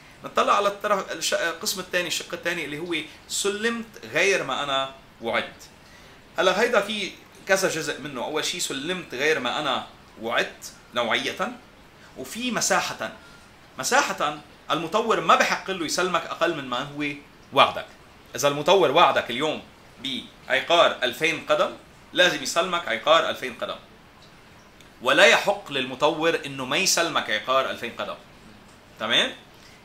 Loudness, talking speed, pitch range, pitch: -23 LUFS, 125 wpm, 140-190 Hz, 170 Hz